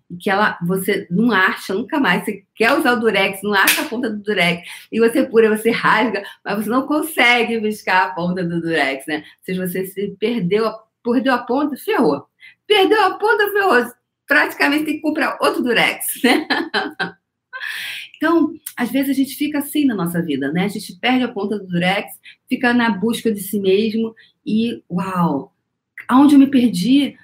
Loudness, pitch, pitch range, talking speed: -17 LUFS, 225 Hz, 195-270 Hz, 180 wpm